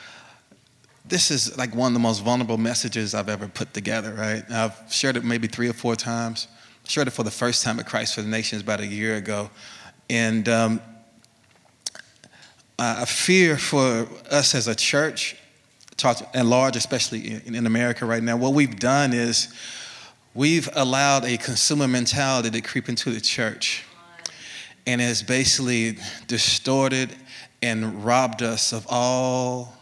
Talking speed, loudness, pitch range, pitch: 155 wpm, -22 LUFS, 115-130 Hz, 120 Hz